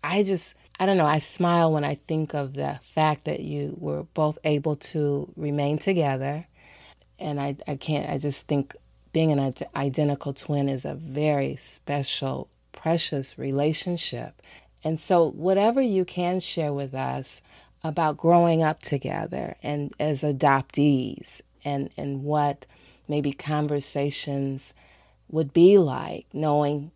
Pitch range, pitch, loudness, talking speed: 140-160 Hz, 150 Hz, -25 LUFS, 140 wpm